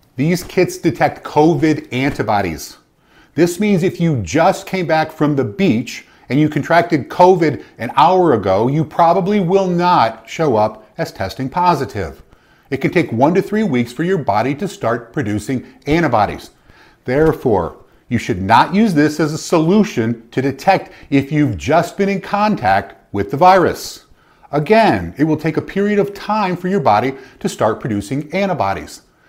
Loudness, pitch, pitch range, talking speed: -16 LUFS, 155 Hz, 125-180 Hz, 165 wpm